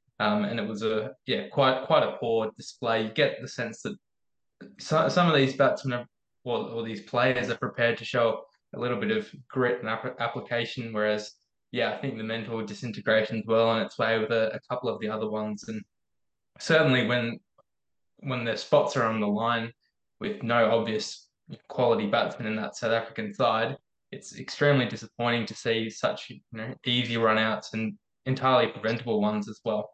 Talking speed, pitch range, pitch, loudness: 190 wpm, 110-125 Hz, 115 Hz, -27 LUFS